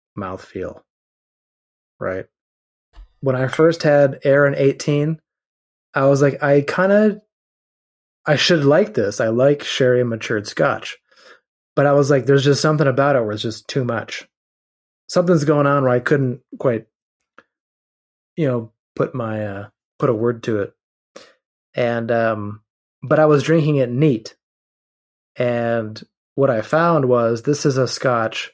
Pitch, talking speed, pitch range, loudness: 135 Hz, 150 wpm, 115-150 Hz, -18 LUFS